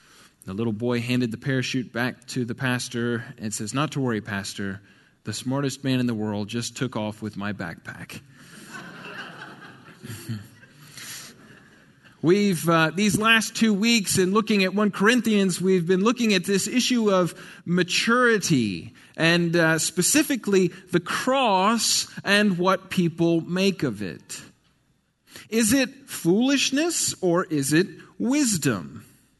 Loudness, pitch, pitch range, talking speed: -23 LUFS, 170 Hz, 125-200 Hz, 135 wpm